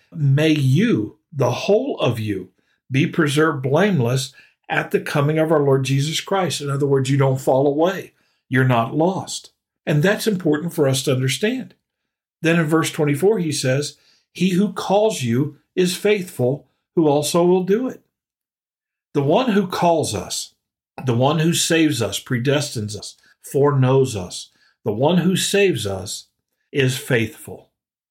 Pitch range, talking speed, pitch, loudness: 135-175 Hz, 155 wpm, 150 Hz, -19 LUFS